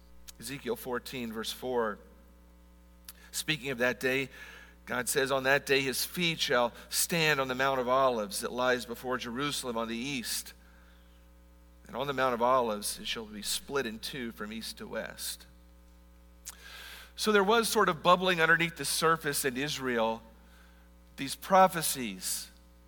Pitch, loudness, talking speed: 125 Hz, -30 LUFS, 150 wpm